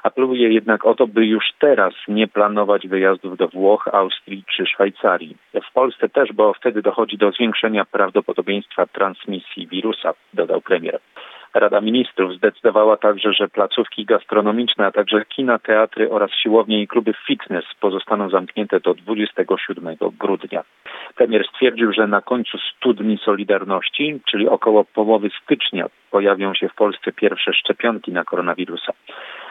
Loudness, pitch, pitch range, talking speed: -18 LUFS, 105 Hz, 100-115 Hz, 140 wpm